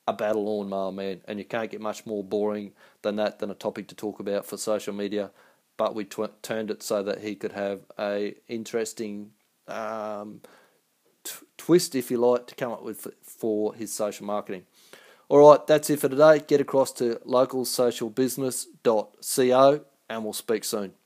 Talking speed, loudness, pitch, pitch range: 180 wpm, -25 LUFS, 110 Hz, 105-125 Hz